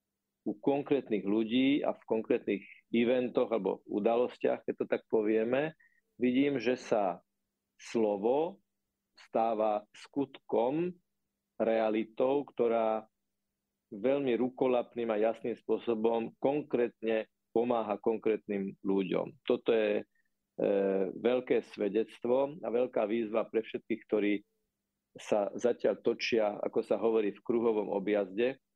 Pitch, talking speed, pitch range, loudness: 115 Hz, 105 wpm, 110-125 Hz, -32 LUFS